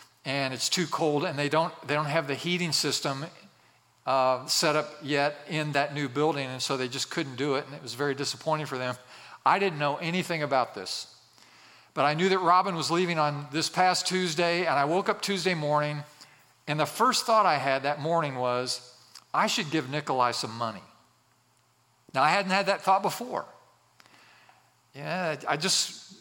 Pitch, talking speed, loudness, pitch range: 150 Hz, 190 wpm, -27 LUFS, 135-175 Hz